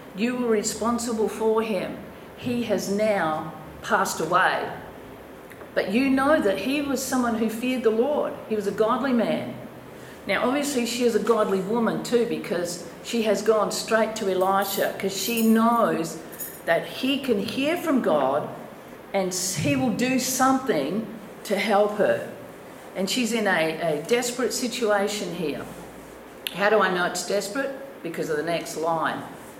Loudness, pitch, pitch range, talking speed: -24 LUFS, 220 Hz, 195-240 Hz, 155 wpm